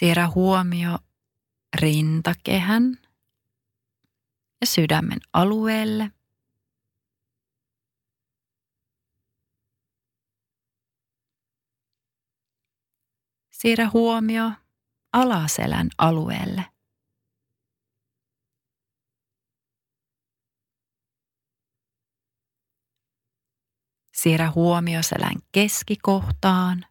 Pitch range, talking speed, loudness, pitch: 115-170 Hz, 30 wpm, -22 LUFS, 125 Hz